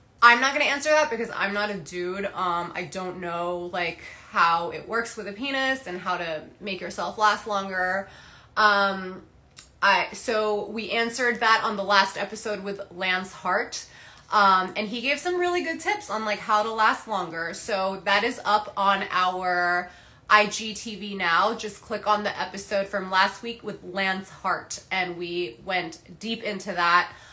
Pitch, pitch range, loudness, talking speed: 200 Hz, 180-215 Hz, -25 LUFS, 175 wpm